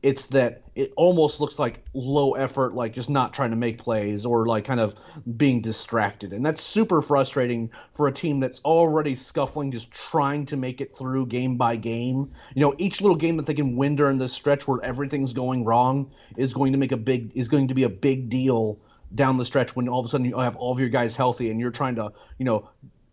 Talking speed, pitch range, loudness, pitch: 235 wpm, 120-140 Hz, -24 LUFS, 130 Hz